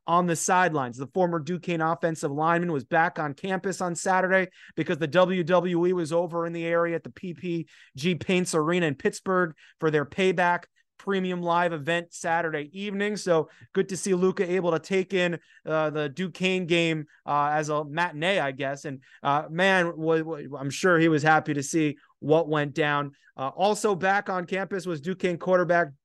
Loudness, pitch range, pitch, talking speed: -26 LUFS, 155-185 Hz, 170 Hz, 175 wpm